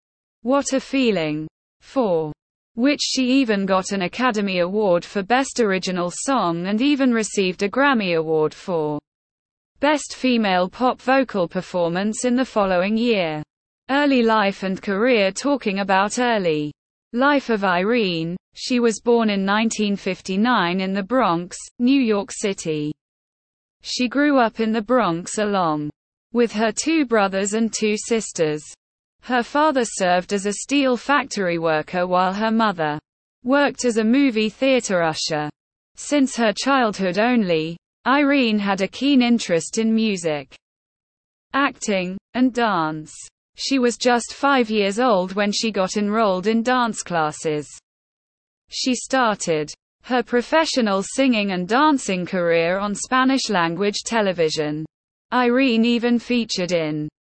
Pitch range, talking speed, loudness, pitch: 180-245 Hz, 130 wpm, -20 LUFS, 210 Hz